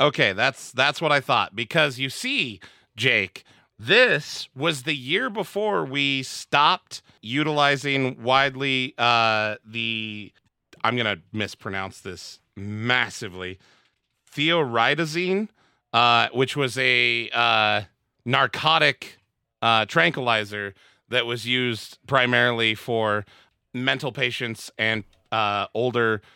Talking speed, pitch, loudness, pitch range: 100 wpm, 120 Hz, -22 LUFS, 110-135 Hz